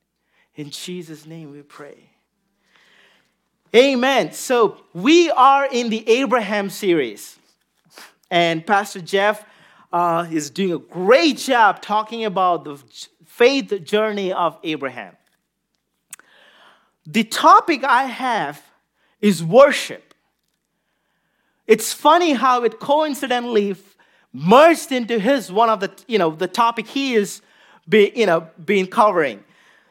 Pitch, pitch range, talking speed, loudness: 215 Hz, 180-255 Hz, 110 wpm, -17 LUFS